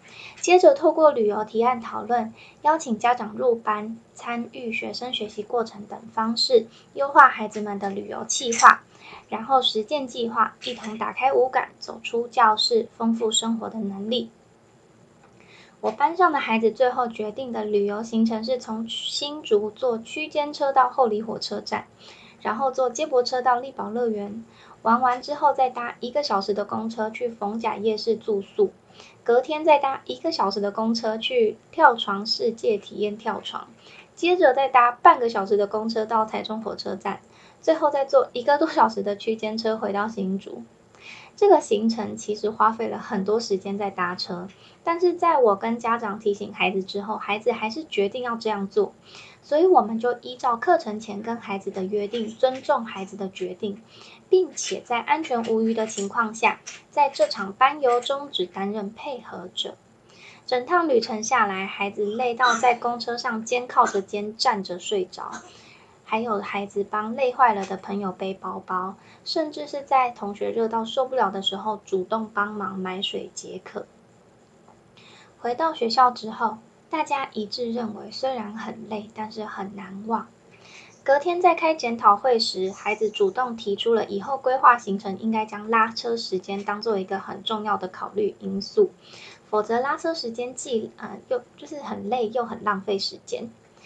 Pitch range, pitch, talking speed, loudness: 210-260 Hz, 225 Hz, 255 characters per minute, -23 LUFS